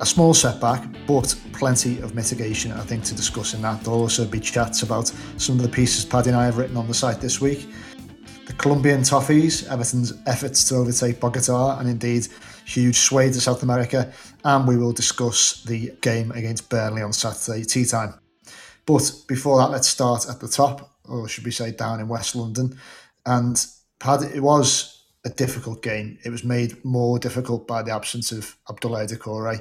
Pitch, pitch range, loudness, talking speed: 120 Hz, 115-130 Hz, -21 LUFS, 190 wpm